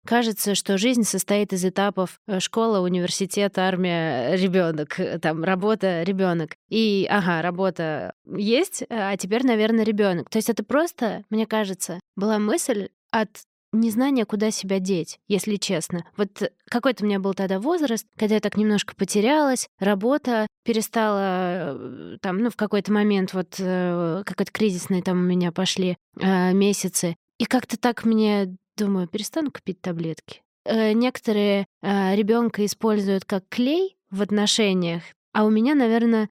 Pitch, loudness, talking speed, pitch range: 205 Hz, -23 LUFS, 140 wpm, 185-220 Hz